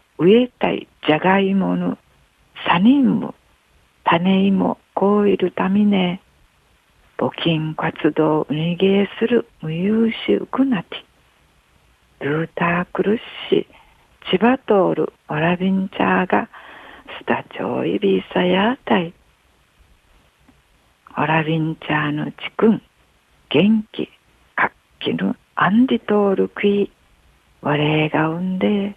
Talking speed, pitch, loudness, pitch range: 215 characters per minute, 185 Hz, -19 LUFS, 155-205 Hz